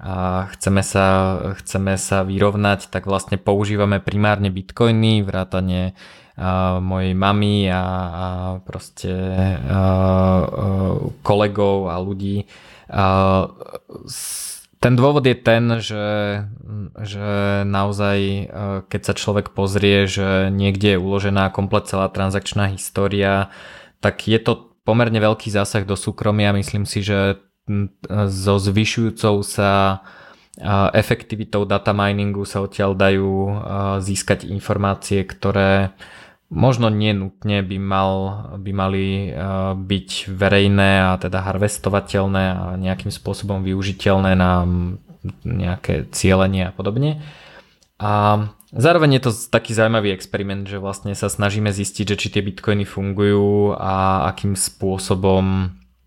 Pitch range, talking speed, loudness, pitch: 95-105 Hz, 115 wpm, -19 LUFS, 100 Hz